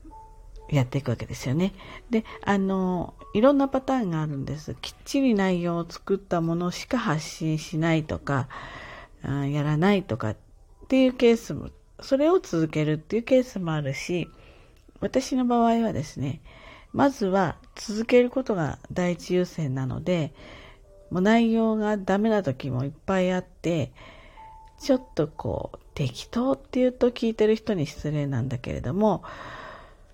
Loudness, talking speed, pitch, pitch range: -26 LUFS, 310 characters per minute, 185 Hz, 150-230 Hz